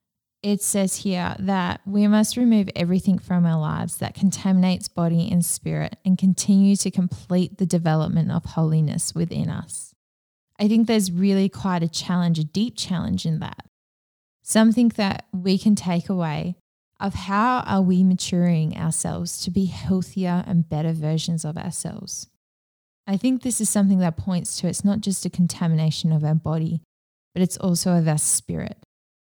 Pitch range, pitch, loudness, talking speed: 160-195 Hz, 180 Hz, -22 LUFS, 165 wpm